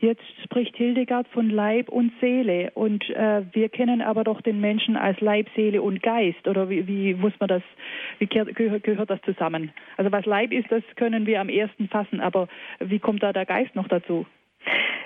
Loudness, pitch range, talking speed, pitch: -24 LUFS, 195-230 Hz, 190 wpm, 215 Hz